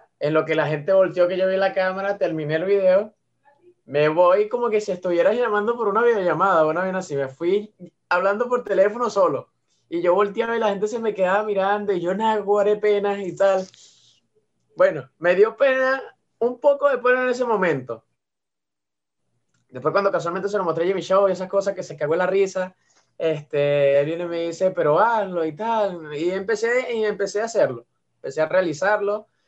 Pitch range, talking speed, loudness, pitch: 170-215 Hz, 195 wpm, -21 LUFS, 195 Hz